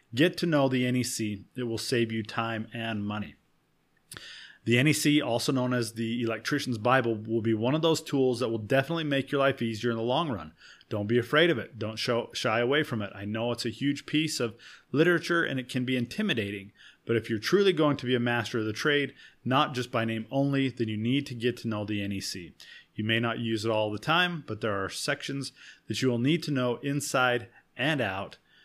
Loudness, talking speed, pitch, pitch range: -28 LUFS, 225 wpm, 120 Hz, 110-140 Hz